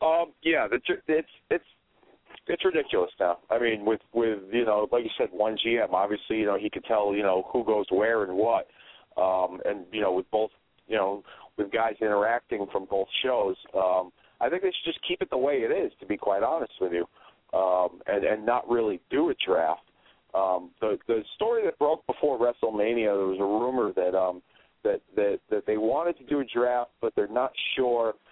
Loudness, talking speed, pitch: -27 LUFS, 210 wpm, 120 Hz